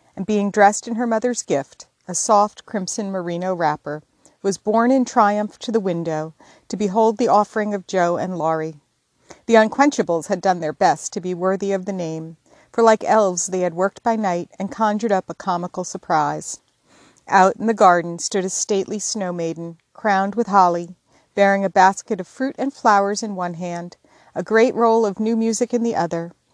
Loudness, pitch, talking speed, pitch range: -19 LUFS, 195 Hz, 190 wpm, 180-220 Hz